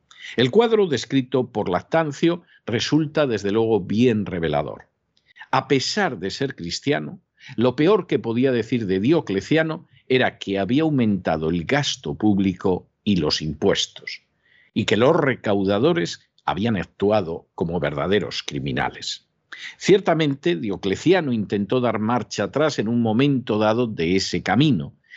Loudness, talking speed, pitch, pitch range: -21 LUFS, 130 wpm, 125 Hz, 100-145 Hz